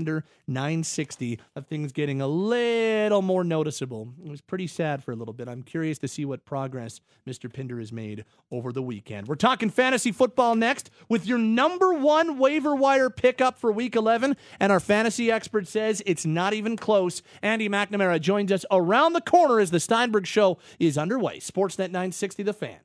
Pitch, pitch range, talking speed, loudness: 190 Hz, 145-230 Hz, 185 wpm, -24 LUFS